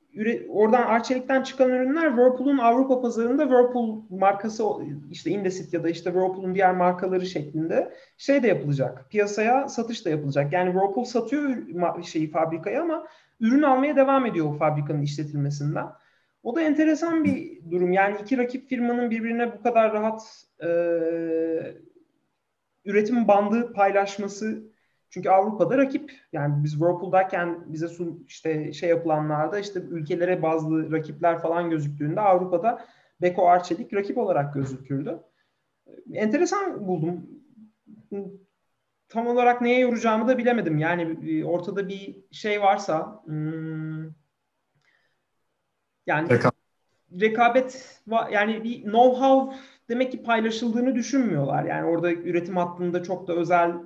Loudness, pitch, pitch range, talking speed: -24 LUFS, 200 Hz, 170-245 Hz, 120 wpm